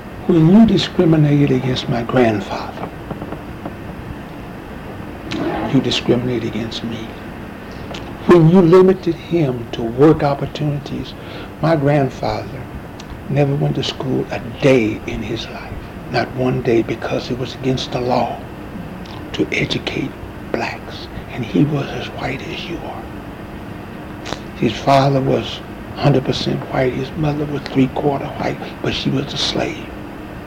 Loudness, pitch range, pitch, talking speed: -17 LUFS, 115-145 Hz, 130 Hz, 125 wpm